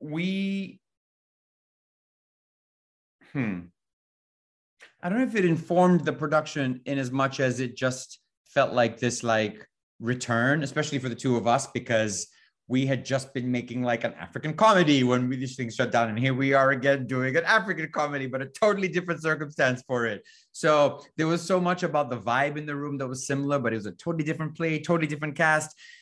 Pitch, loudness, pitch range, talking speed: 140 Hz, -26 LUFS, 125-155 Hz, 190 wpm